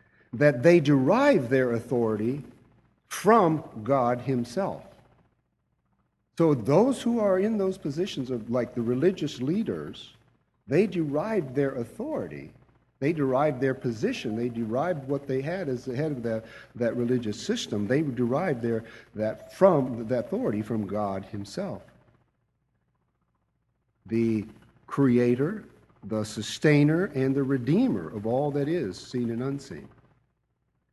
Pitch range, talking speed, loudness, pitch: 115-155 Hz, 125 wpm, -26 LUFS, 130 Hz